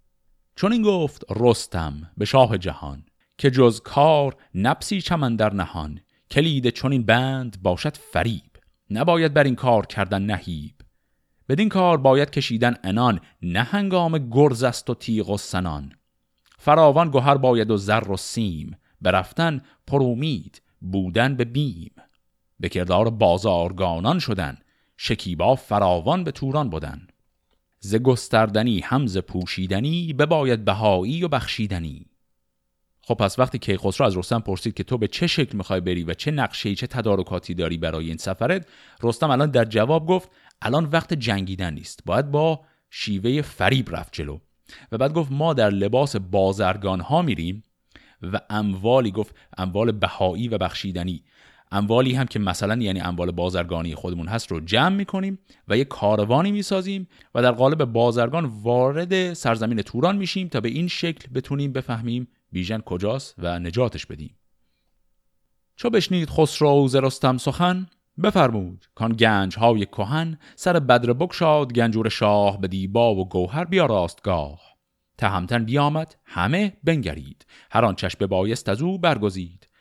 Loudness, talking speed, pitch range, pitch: -22 LUFS, 145 wpm, 95-140 Hz, 115 Hz